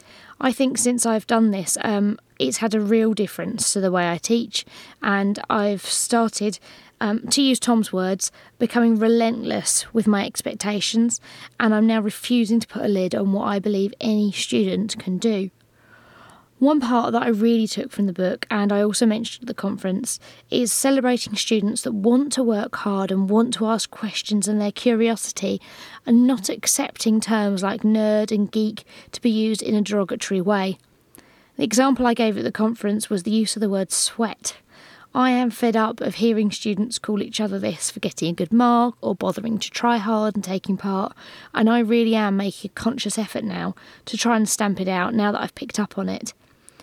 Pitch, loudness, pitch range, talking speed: 220 Hz, -21 LUFS, 205-235 Hz, 195 wpm